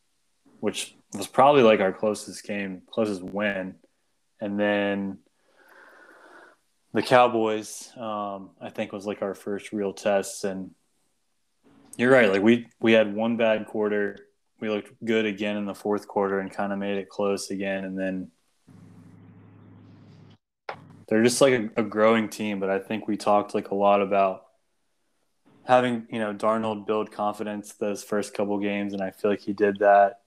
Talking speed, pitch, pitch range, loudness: 165 wpm, 105 Hz, 100-110 Hz, -25 LUFS